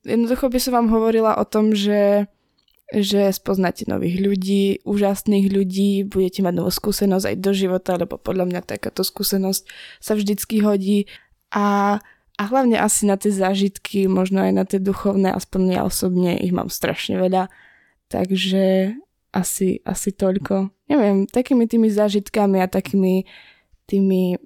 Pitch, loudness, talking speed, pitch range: 195 Hz, -20 LUFS, 145 wpm, 190-210 Hz